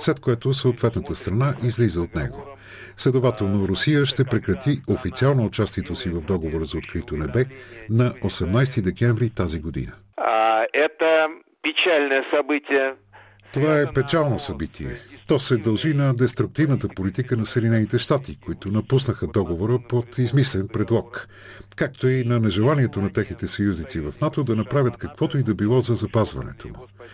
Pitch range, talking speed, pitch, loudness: 100-135 Hz, 140 wpm, 120 Hz, -22 LUFS